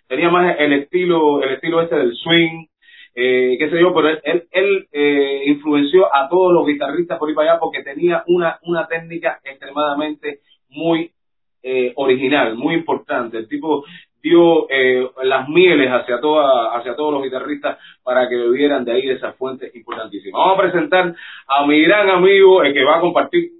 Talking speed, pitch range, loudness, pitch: 185 wpm, 140-180 Hz, -16 LUFS, 160 Hz